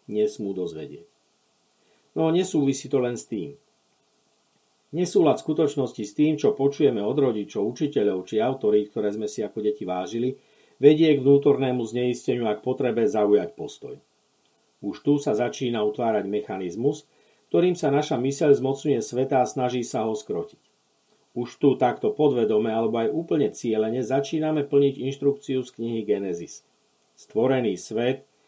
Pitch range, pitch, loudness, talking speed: 110-140 Hz, 130 Hz, -24 LUFS, 140 wpm